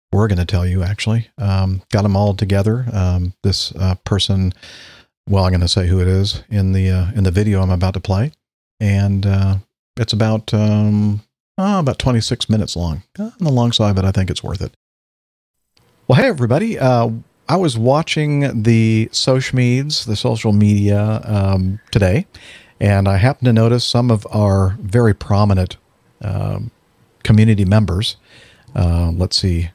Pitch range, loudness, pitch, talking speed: 95-115 Hz, -16 LUFS, 105 Hz, 170 wpm